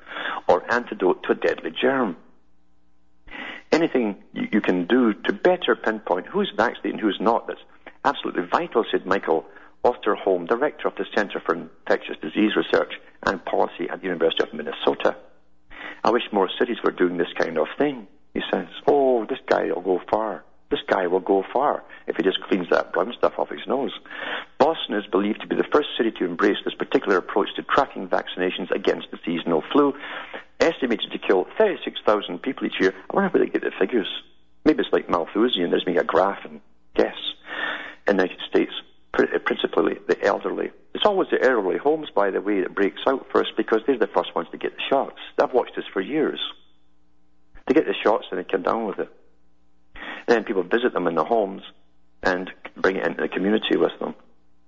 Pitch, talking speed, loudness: 90 Hz, 190 wpm, -23 LUFS